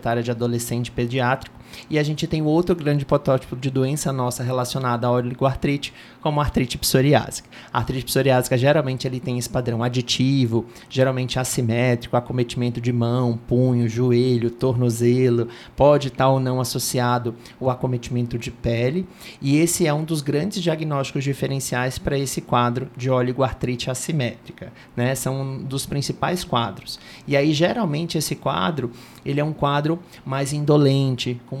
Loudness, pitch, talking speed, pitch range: -22 LUFS, 130 Hz, 150 wpm, 125-145 Hz